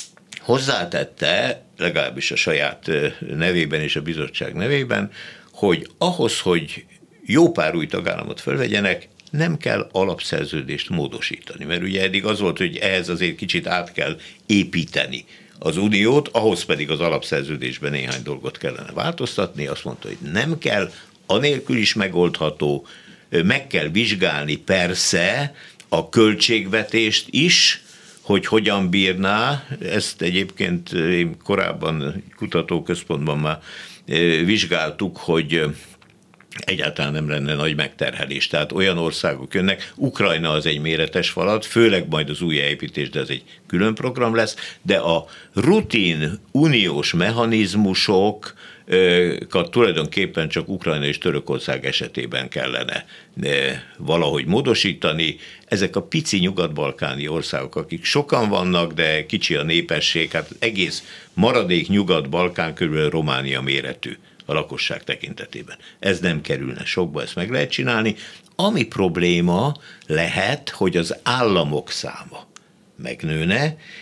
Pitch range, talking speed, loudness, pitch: 75-110 Hz, 120 wpm, -20 LUFS, 90 Hz